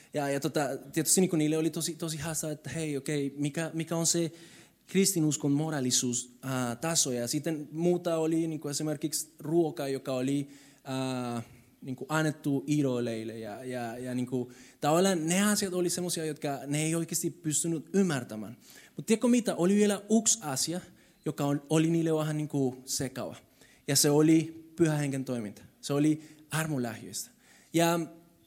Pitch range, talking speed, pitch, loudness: 135-165 Hz, 150 wpm, 155 Hz, -30 LUFS